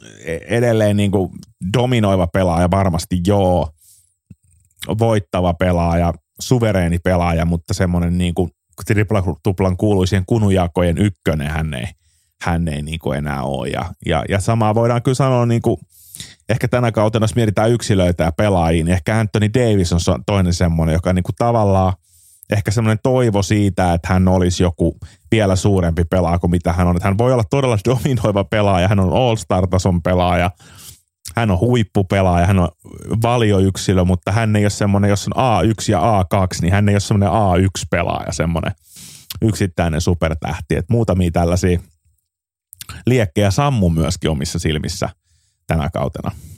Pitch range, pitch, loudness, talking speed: 90-105 Hz, 95 Hz, -17 LUFS, 140 wpm